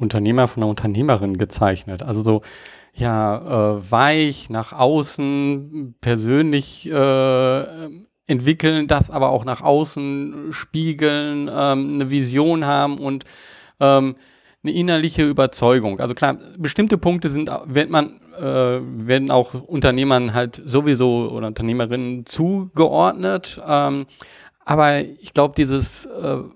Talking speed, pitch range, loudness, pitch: 115 wpm, 120-150 Hz, -19 LUFS, 135 Hz